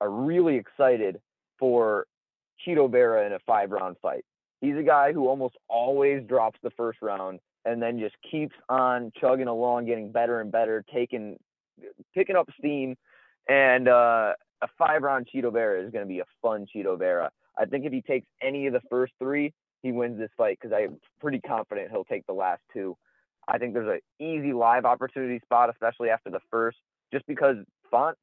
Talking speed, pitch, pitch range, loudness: 190 wpm, 125 Hz, 115-140 Hz, -26 LUFS